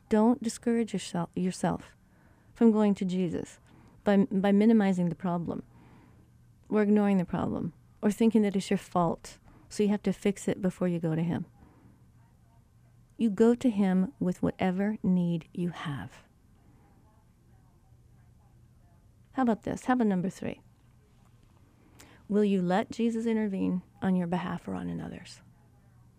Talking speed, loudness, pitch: 135 wpm, -29 LUFS, 185 Hz